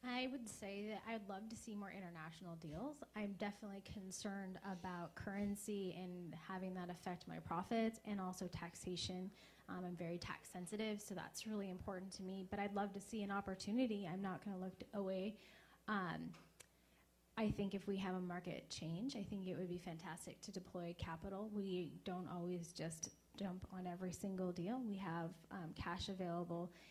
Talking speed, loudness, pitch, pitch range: 180 wpm, -48 LUFS, 190 Hz, 180-205 Hz